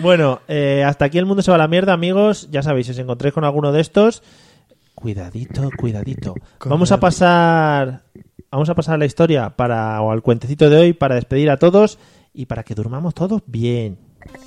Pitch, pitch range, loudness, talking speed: 145 Hz, 125-170 Hz, -16 LUFS, 200 wpm